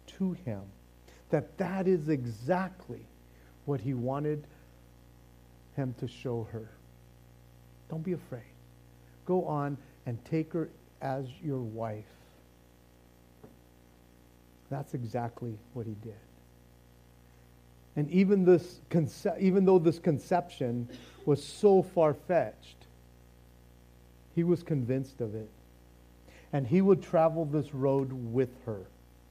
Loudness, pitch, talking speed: -31 LUFS, 115 Hz, 110 wpm